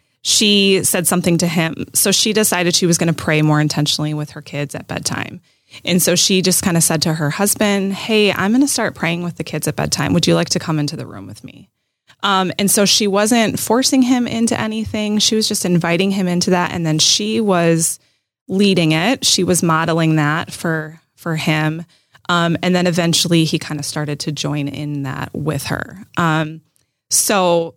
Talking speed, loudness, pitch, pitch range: 205 wpm, -16 LUFS, 170 Hz, 155-195 Hz